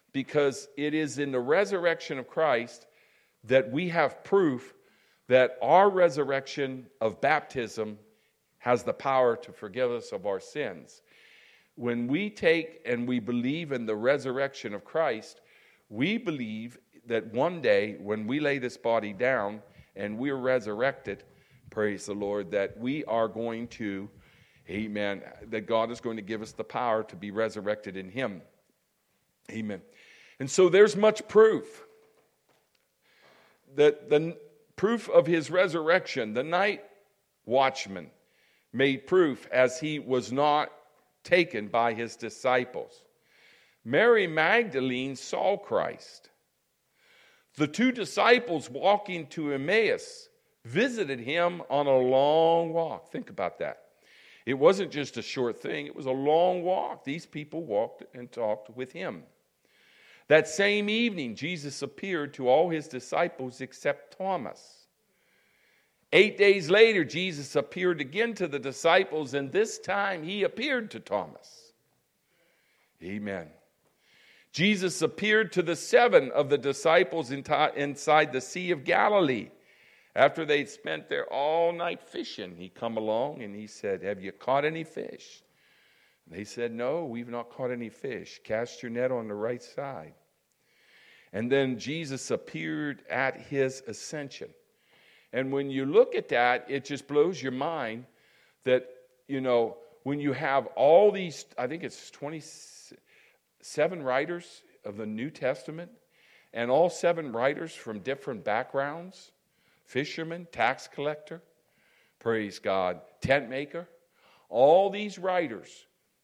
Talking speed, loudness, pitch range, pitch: 135 wpm, -28 LUFS, 125-175 Hz, 145 Hz